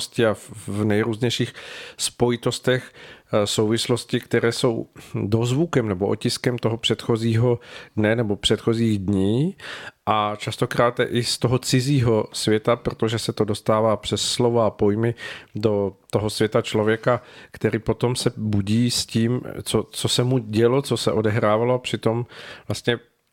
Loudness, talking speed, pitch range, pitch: -22 LUFS, 135 wpm, 110-120 Hz, 115 Hz